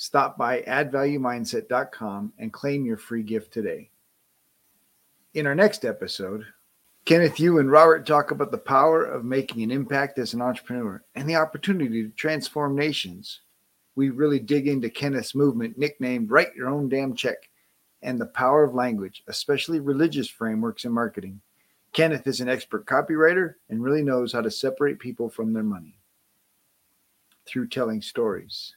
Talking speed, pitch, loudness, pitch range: 155 wpm, 140 Hz, -24 LUFS, 120-150 Hz